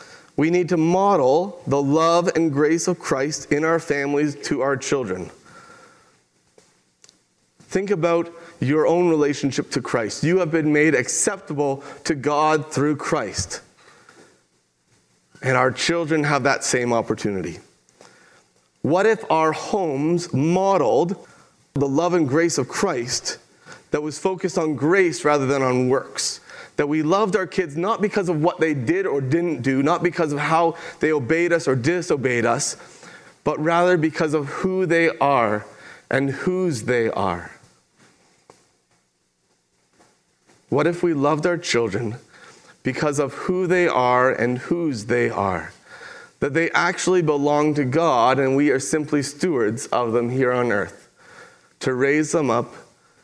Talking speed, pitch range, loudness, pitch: 145 wpm, 135-175 Hz, -21 LUFS, 155 Hz